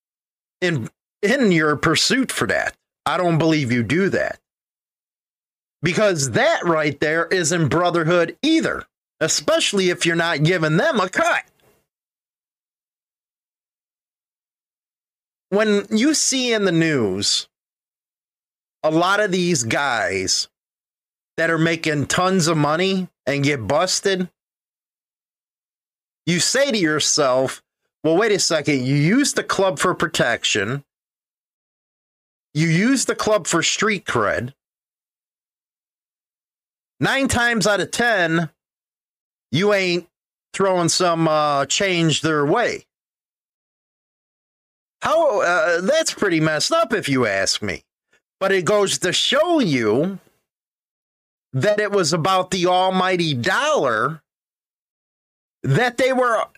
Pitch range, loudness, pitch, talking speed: 155-205 Hz, -19 LUFS, 175 Hz, 115 wpm